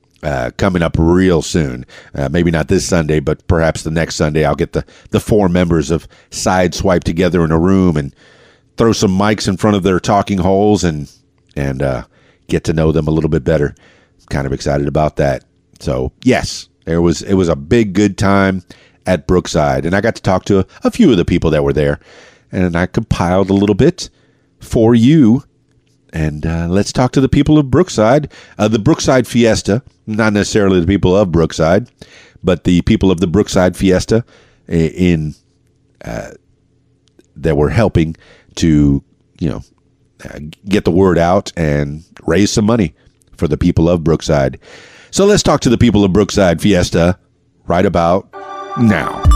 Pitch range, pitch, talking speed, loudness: 80-105 Hz, 90 Hz, 180 wpm, -14 LUFS